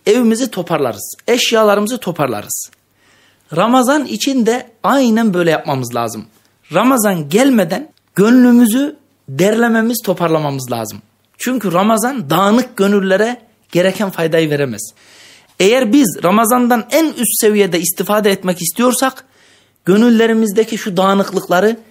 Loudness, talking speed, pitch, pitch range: -13 LUFS, 100 wpm, 205 Hz, 170-240 Hz